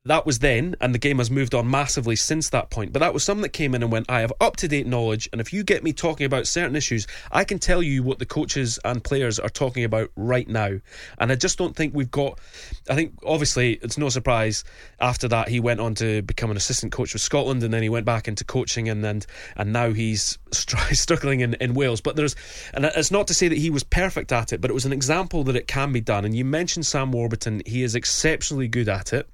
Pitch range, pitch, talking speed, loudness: 115-150 Hz, 125 Hz, 260 wpm, -23 LUFS